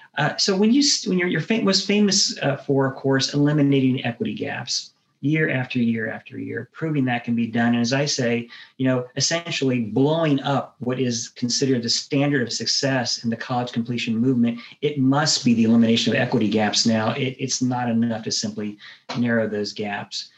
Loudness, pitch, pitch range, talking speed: -21 LUFS, 130 Hz, 115-145 Hz, 195 wpm